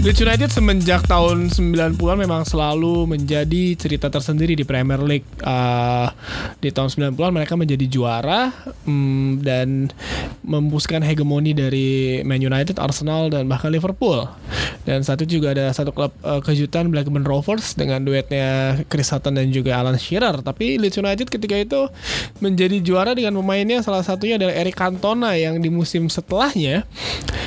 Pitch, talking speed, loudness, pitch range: 150 Hz, 145 wpm, -19 LUFS, 135-185 Hz